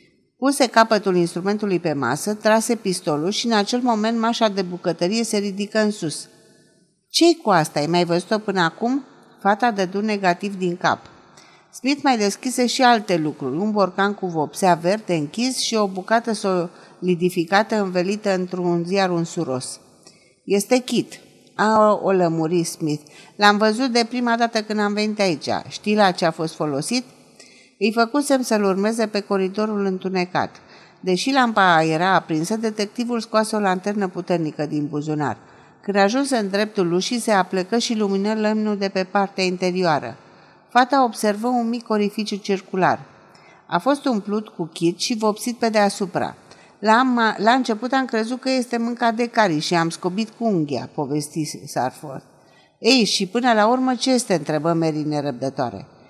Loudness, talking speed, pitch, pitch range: -20 LUFS, 155 wpm, 200 Hz, 175-225 Hz